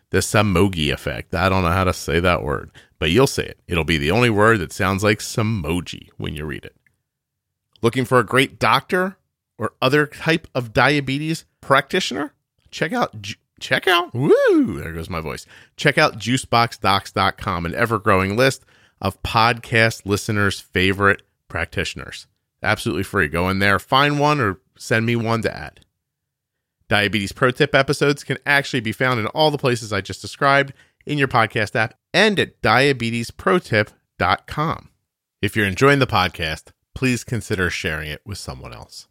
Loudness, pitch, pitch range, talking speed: -19 LUFS, 110 Hz, 95-130 Hz, 165 wpm